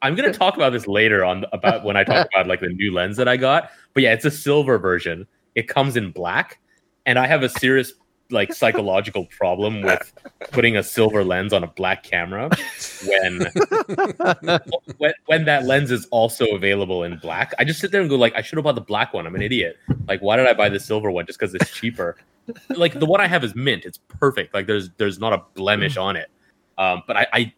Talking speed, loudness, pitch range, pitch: 230 wpm, -20 LUFS, 105-145 Hz, 120 Hz